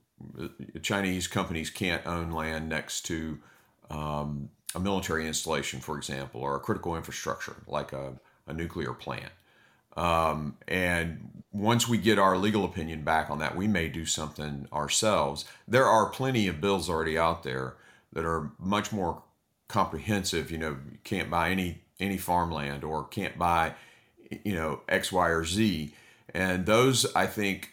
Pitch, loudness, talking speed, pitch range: 80 Hz, -29 LUFS, 155 wpm, 75-95 Hz